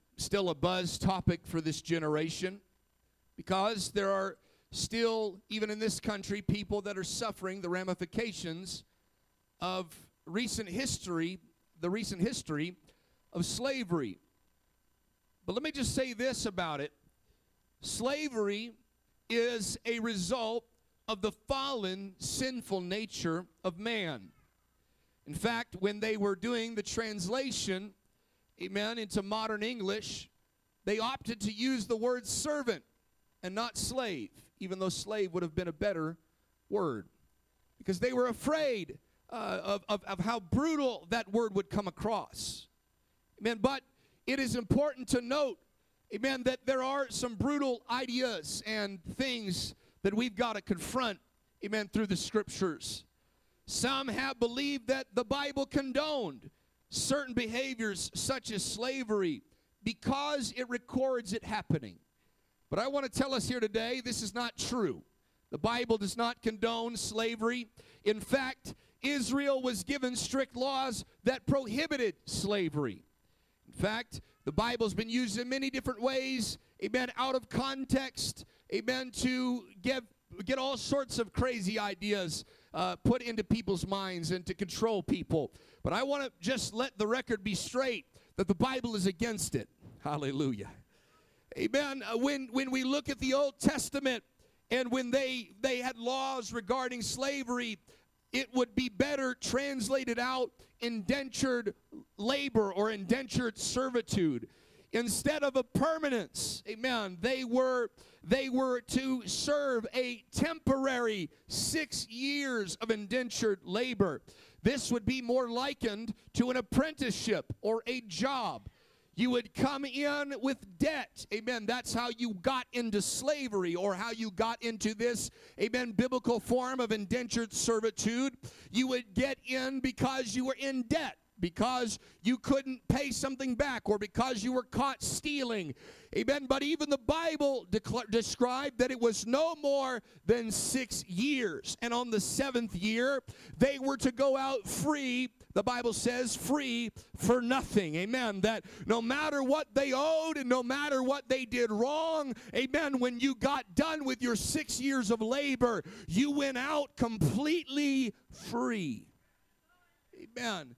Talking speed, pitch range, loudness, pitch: 140 wpm, 210-265 Hz, -34 LUFS, 240 Hz